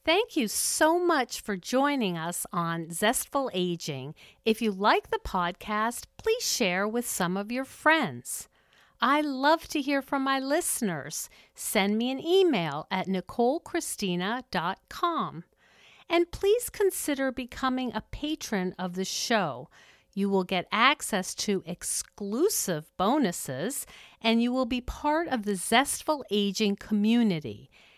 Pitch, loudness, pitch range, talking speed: 230 Hz, -28 LUFS, 190-290 Hz, 130 wpm